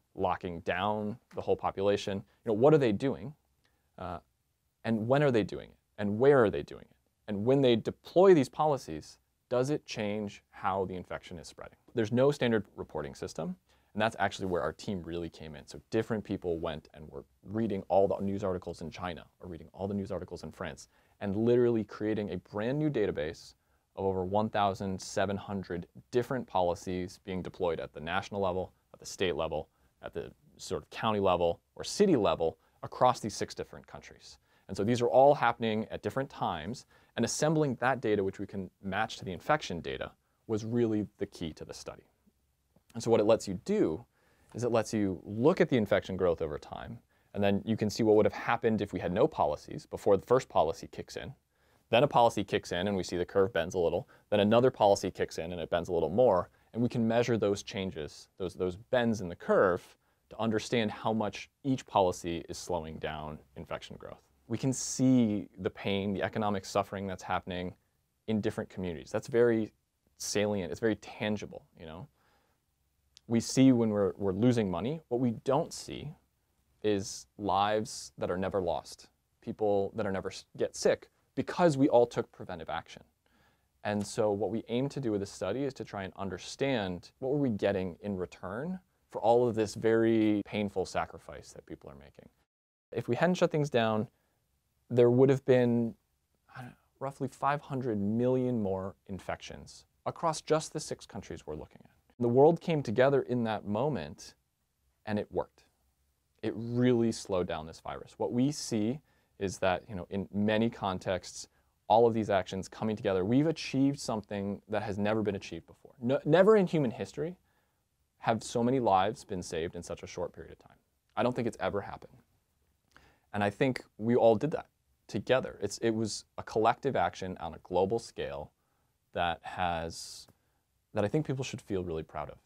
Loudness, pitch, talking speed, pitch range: -31 LUFS, 105 Hz, 190 wpm, 95-120 Hz